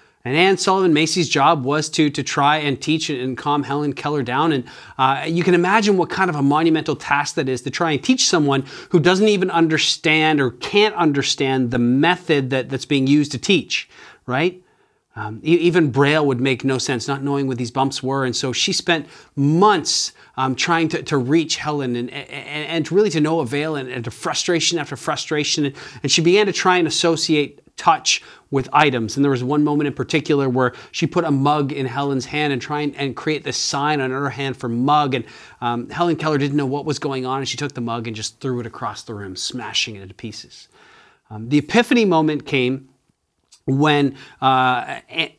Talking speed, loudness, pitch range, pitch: 210 wpm, -19 LUFS, 130-160 Hz, 145 Hz